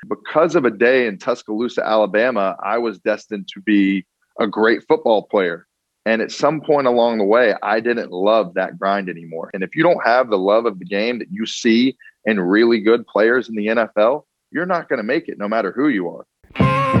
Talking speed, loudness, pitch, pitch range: 210 wpm, -18 LUFS, 110 Hz, 100-120 Hz